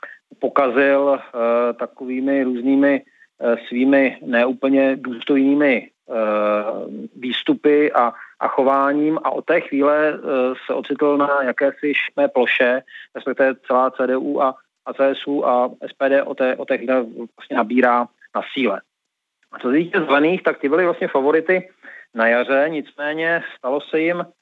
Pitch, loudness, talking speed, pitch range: 135 Hz, -19 LUFS, 140 wpm, 125-145 Hz